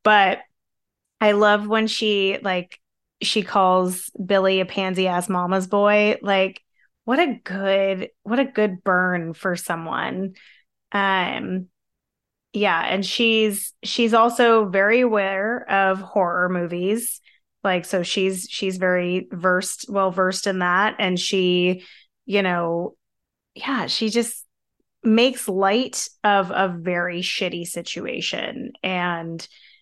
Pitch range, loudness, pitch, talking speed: 185-215 Hz, -21 LUFS, 195 Hz, 120 wpm